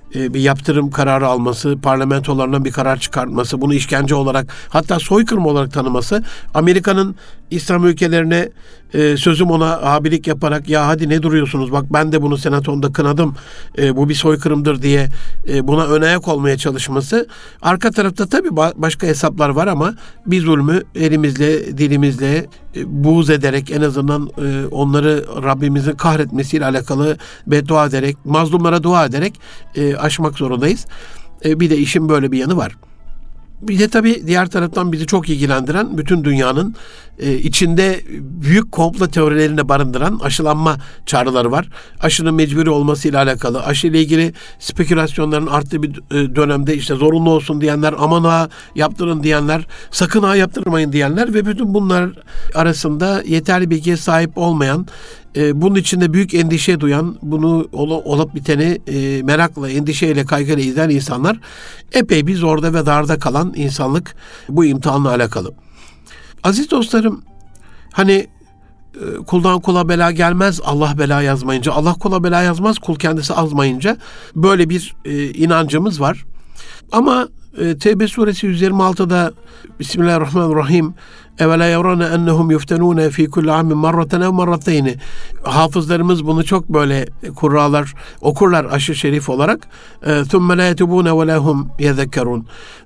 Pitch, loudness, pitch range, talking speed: 155 Hz, -15 LUFS, 145-175 Hz, 130 wpm